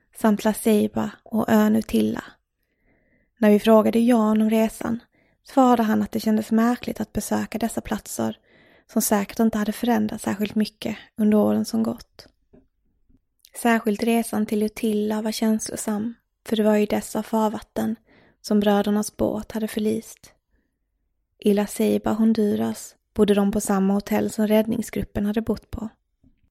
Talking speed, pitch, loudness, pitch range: 145 wpm, 215 Hz, -22 LUFS, 210-225 Hz